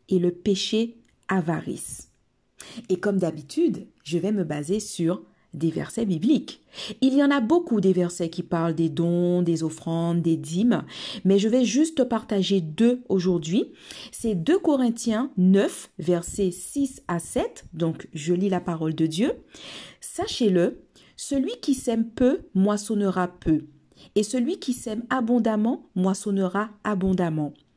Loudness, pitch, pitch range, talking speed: -24 LUFS, 195 Hz, 175-235 Hz, 145 wpm